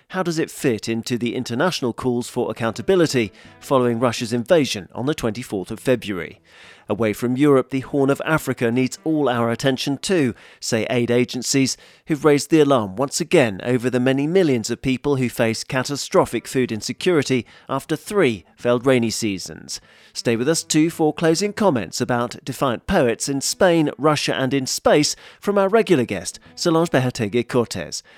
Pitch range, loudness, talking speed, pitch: 120-150 Hz, -20 LUFS, 165 wpm, 130 Hz